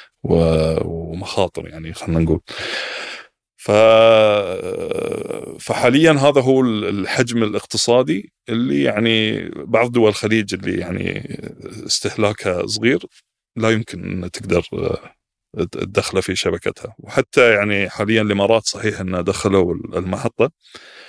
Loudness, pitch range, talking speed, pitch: -18 LUFS, 90-120 Hz, 95 wpm, 110 Hz